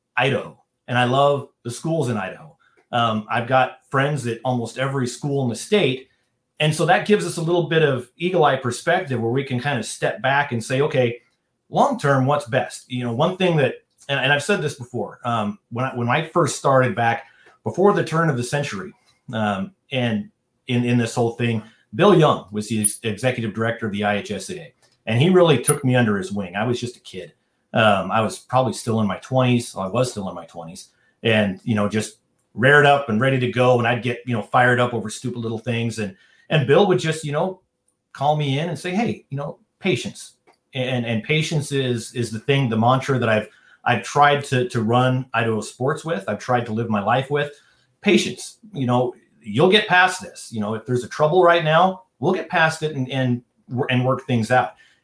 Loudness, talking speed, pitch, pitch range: -20 LUFS, 220 wpm, 125 Hz, 115-145 Hz